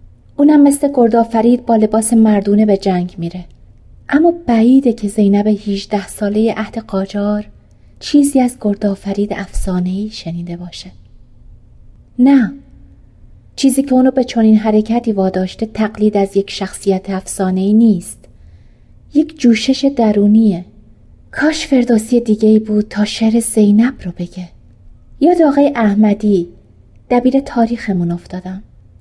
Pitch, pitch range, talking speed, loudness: 210 Hz, 180-235 Hz, 120 wpm, -13 LUFS